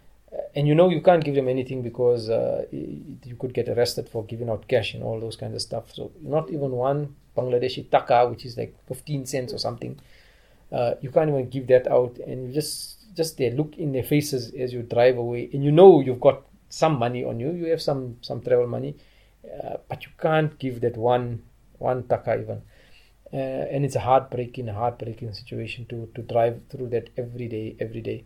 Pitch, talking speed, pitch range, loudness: 125 Hz, 210 wpm, 120-140 Hz, -24 LUFS